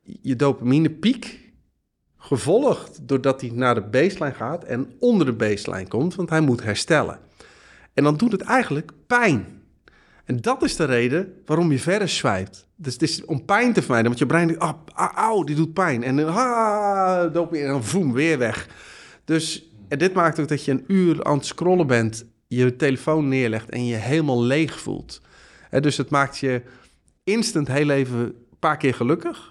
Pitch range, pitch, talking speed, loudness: 125-170 Hz, 150 Hz, 185 wpm, -21 LUFS